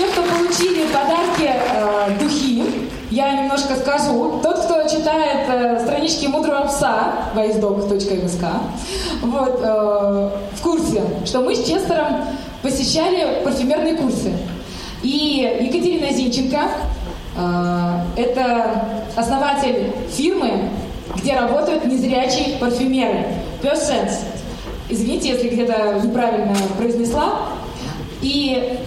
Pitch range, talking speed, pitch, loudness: 225-295 Hz, 95 wpm, 260 Hz, -19 LUFS